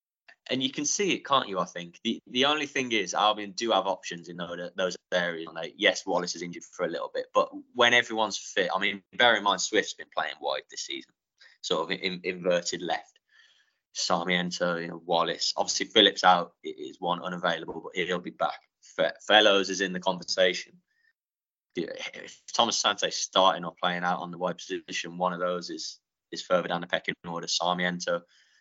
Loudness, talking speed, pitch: -27 LUFS, 195 wpm, 100 Hz